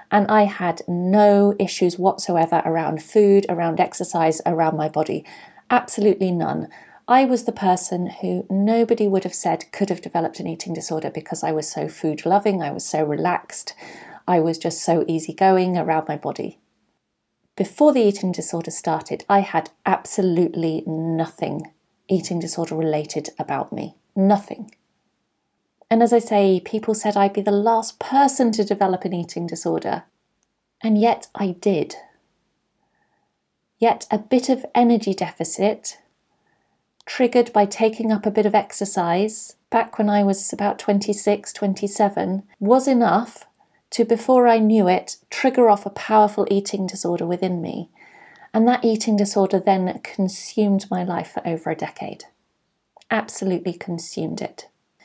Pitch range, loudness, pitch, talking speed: 170-215 Hz, -20 LUFS, 195 Hz, 145 wpm